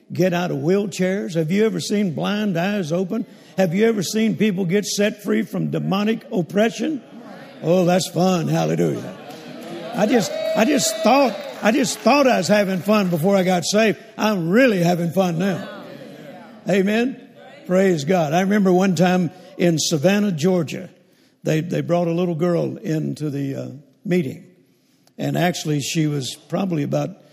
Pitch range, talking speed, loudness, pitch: 175-215 Hz, 160 wpm, -20 LUFS, 185 Hz